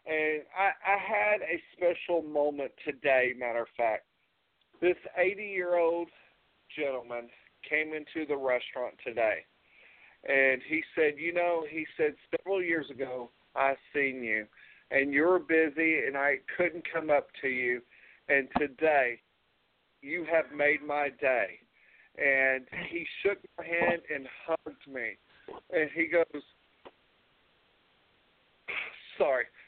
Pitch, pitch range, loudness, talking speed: 155 Hz, 135-175 Hz, -30 LUFS, 125 wpm